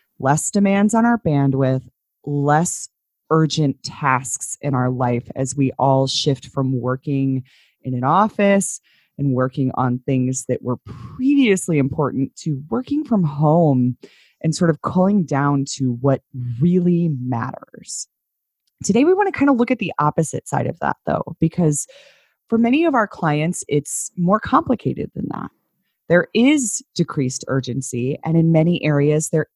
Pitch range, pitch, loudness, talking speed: 135-185 Hz, 150 Hz, -19 LUFS, 150 wpm